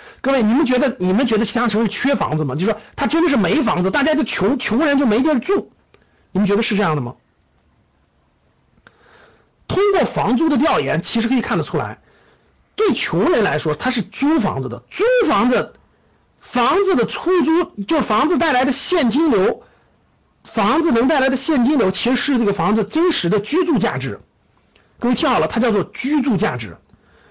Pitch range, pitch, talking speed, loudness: 210-310 Hz, 255 Hz, 280 characters per minute, -17 LUFS